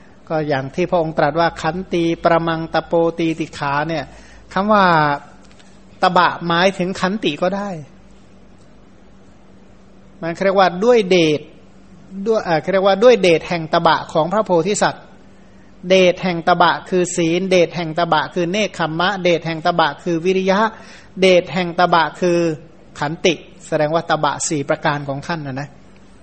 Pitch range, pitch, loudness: 160-185 Hz, 170 Hz, -17 LUFS